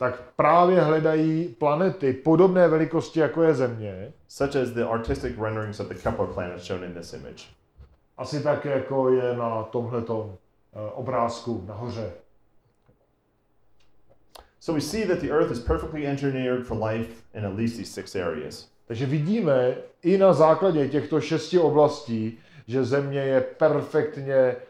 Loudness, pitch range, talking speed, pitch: -24 LUFS, 115-155 Hz, 70 wpm, 130 Hz